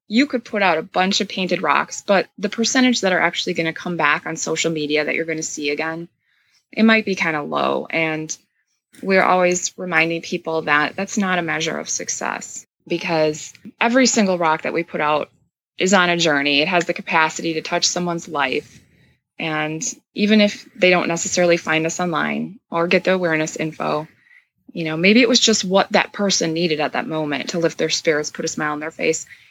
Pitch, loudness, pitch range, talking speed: 170 Hz, -19 LUFS, 160-195 Hz, 210 wpm